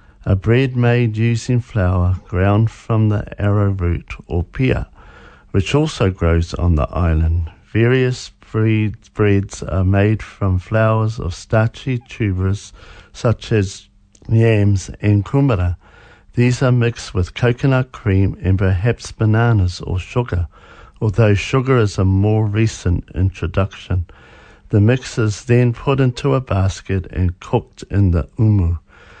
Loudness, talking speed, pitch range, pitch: -18 LUFS, 125 wpm, 90-115 Hz, 100 Hz